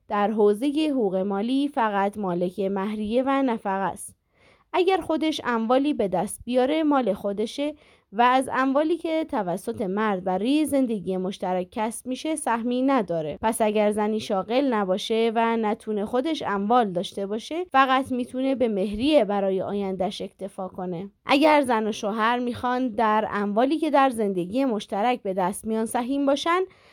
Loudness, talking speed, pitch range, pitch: -24 LUFS, 145 wpm, 200-265 Hz, 225 Hz